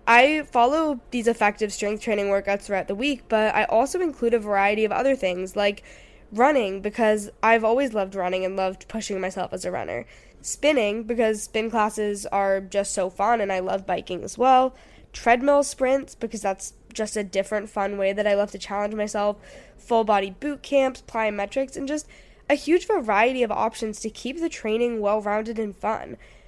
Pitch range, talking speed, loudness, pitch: 200-250 Hz, 185 wpm, -24 LUFS, 215 Hz